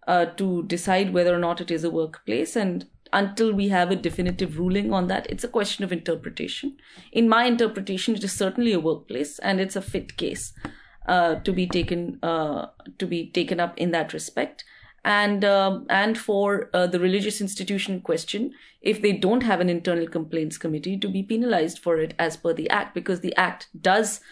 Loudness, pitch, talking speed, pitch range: -24 LUFS, 185 Hz, 195 wpm, 170-205 Hz